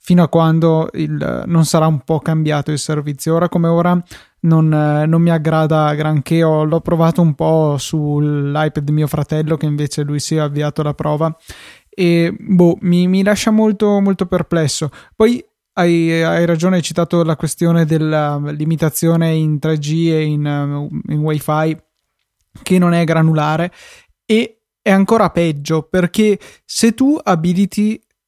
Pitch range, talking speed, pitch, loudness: 155-175 Hz, 150 wpm, 160 Hz, -15 LUFS